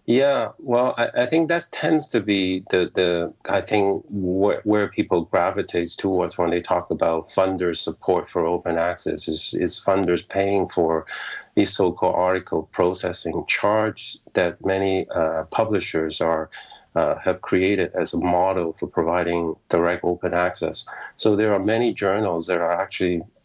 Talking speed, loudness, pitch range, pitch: 155 wpm, -22 LUFS, 85-105 Hz, 95 Hz